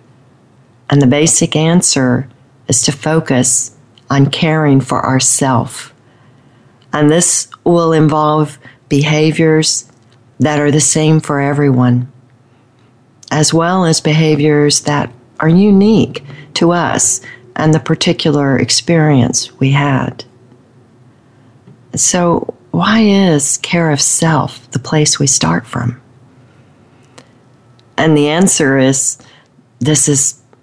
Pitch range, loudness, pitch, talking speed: 125-155 Hz, -11 LUFS, 140 Hz, 105 wpm